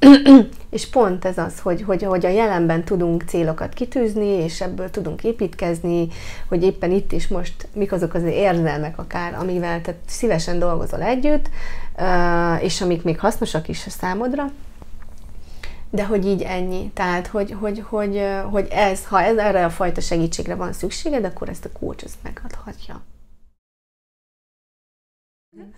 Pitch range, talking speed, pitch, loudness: 175-210 Hz, 140 wpm, 185 Hz, -20 LUFS